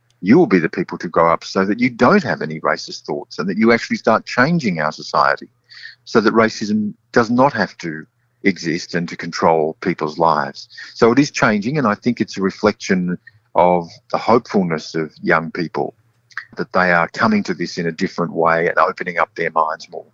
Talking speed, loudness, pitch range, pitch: 205 wpm, -17 LUFS, 85-120 Hz, 100 Hz